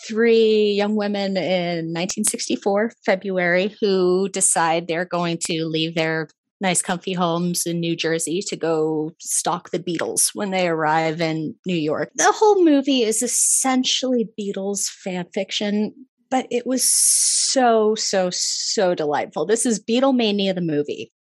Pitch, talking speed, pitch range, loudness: 195 Hz, 140 wpm, 170-230 Hz, -20 LUFS